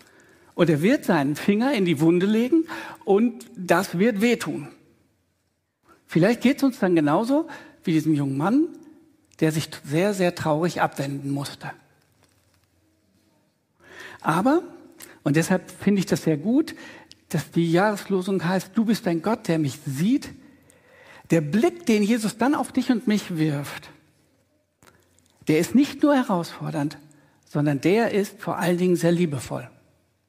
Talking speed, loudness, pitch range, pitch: 145 wpm, -23 LUFS, 155-240 Hz, 180 Hz